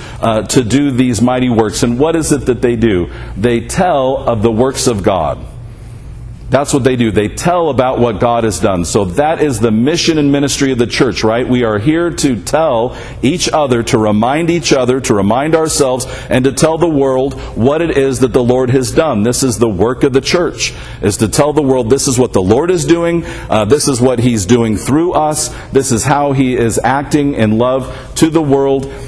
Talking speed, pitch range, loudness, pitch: 220 wpm, 115-140 Hz, -12 LUFS, 130 Hz